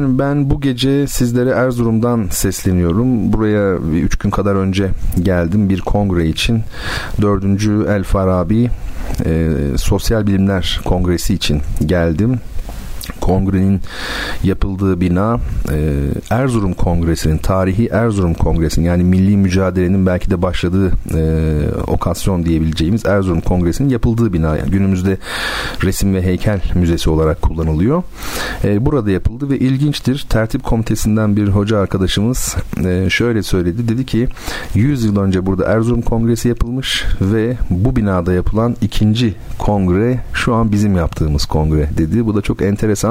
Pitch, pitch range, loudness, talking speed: 95 Hz, 90-115 Hz, -16 LUFS, 125 wpm